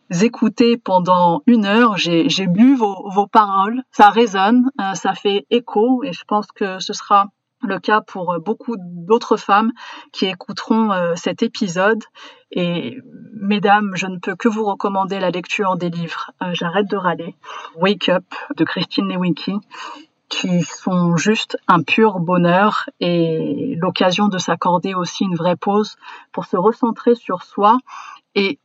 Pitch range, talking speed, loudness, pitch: 180-225 Hz, 150 wpm, -17 LUFS, 200 Hz